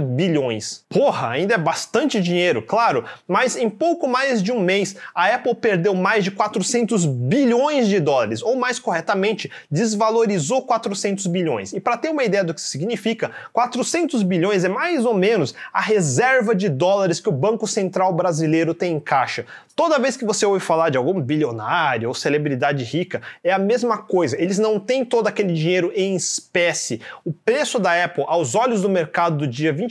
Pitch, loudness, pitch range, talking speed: 200 Hz, -20 LUFS, 175-230 Hz, 185 wpm